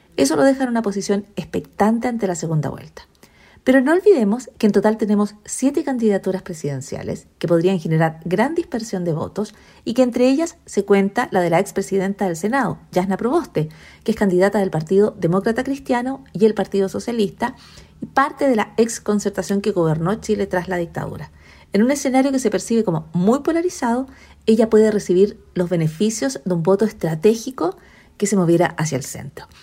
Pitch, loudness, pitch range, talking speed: 205 Hz, -19 LUFS, 180-235 Hz, 180 wpm